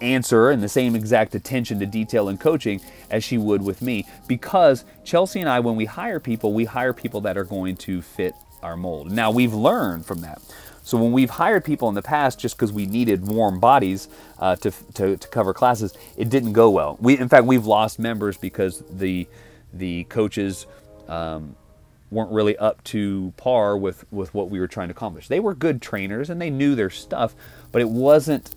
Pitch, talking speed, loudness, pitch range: 110 Hz, 205 wpm, -21 LUFS, 100-125 Hz